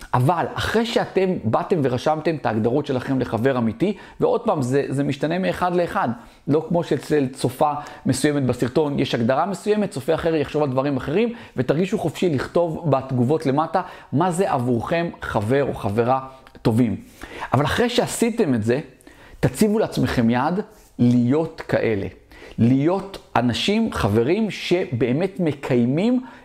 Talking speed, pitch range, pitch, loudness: 135 wpm, 130-185 Hz, 150 Hz, -21 LUFS